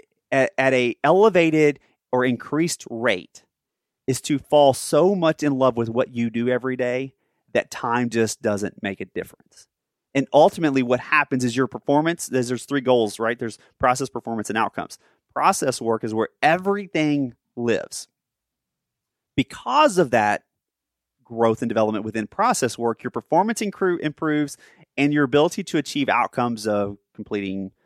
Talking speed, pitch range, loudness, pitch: 150 wpm, 115-150 Hz, -22 LUFS, 130 Hz